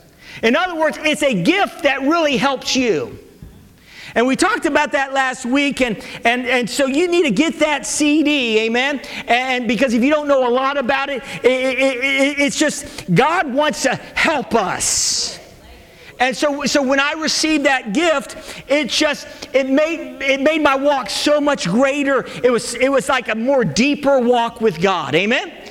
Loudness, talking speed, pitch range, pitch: -16 LUFS, 185 wpm, 250-295 Hz, 275 Hz